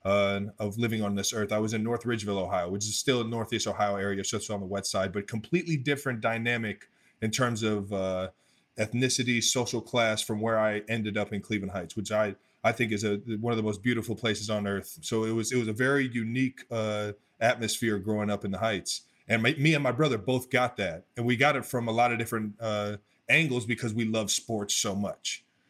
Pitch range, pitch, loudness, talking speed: 105-120 Hz, 110 Hz, -29 LUFS, 230 wpm